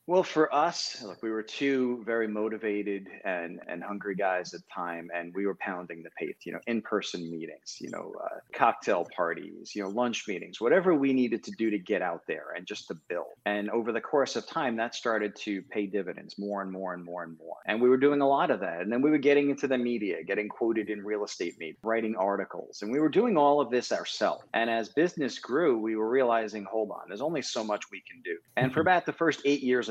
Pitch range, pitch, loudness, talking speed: 100-130 Hz, 110 Hz, -30 LUFS, 245 wpm